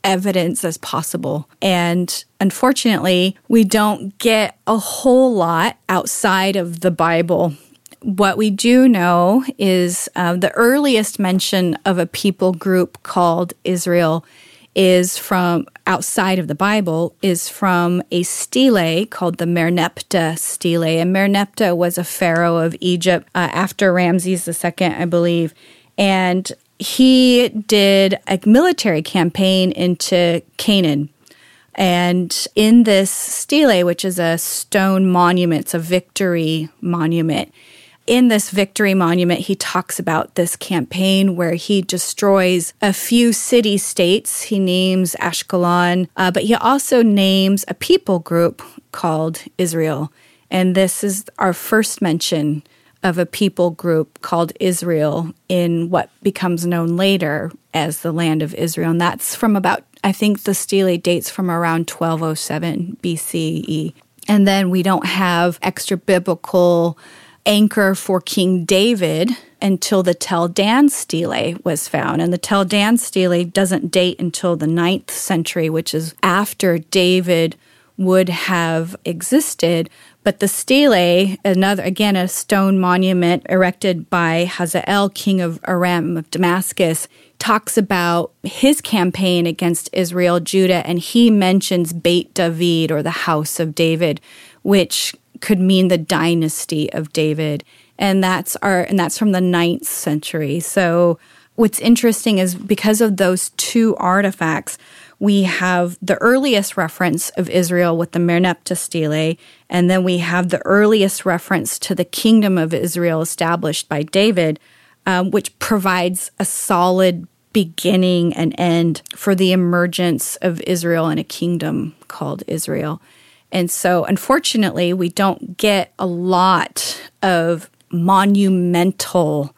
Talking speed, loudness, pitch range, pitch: 135 wpm, -16 LUFS, 170-195 Hz, 180 Hz